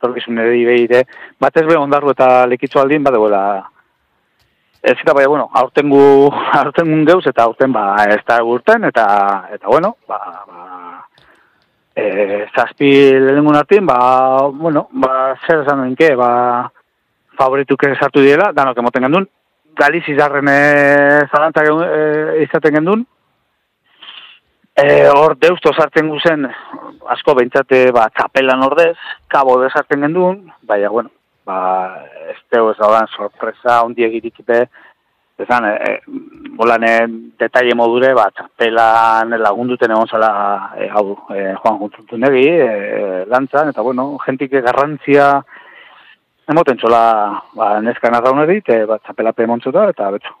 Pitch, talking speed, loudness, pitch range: 130 Hz, 135 wpm, -12 LUFS, 115-145 Hz